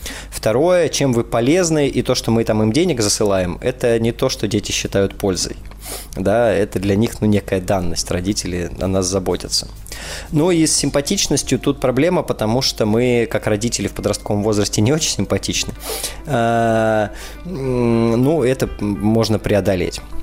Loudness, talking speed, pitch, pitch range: -17 LUFS, 155 wpm, 115 Hz, 100-130 Hz